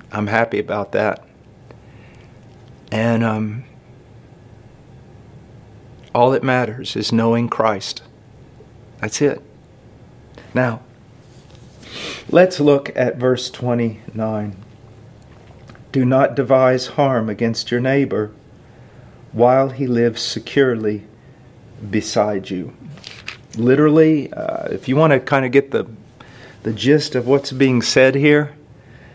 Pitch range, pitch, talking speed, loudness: 115-135 Hz, 125 Hz, 105 wpm, -17 LUFS